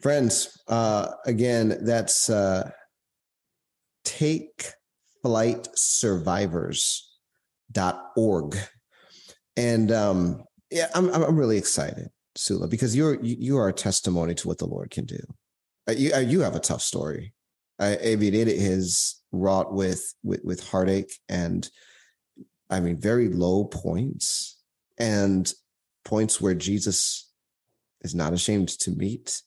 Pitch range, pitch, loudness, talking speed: 95-115 Hz, 105 Hz, -25 LUFS, 115 wpm